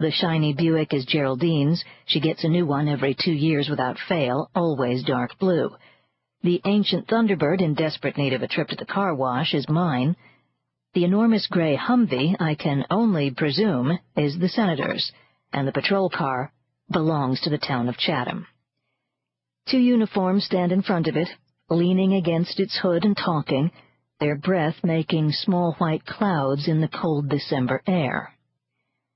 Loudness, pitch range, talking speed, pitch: -23 LUFS, 145-185 Hz, 160 wpm, 160 Hz